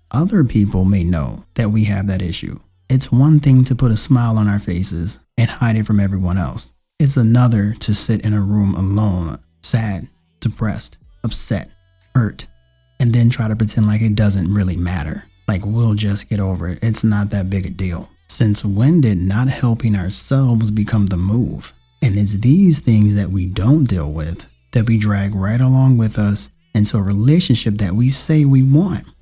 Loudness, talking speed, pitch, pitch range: -16 LUFS, 190 wpm, 105 Hz, 95-120 Hz